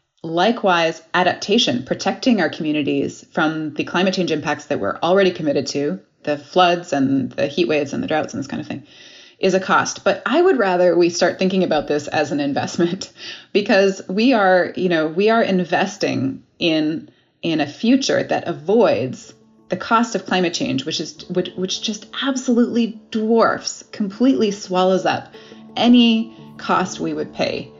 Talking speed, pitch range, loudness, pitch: 170 wpm, 155-215 Hz, -19 LUFS, 180 Hz